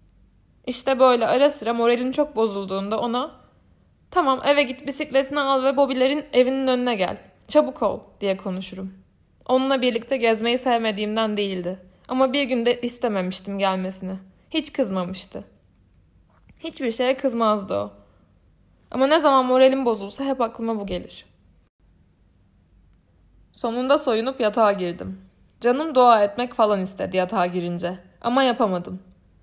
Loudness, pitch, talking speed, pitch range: -22 LUFS, 220 Hz, 125 wpm, 175-260 Hz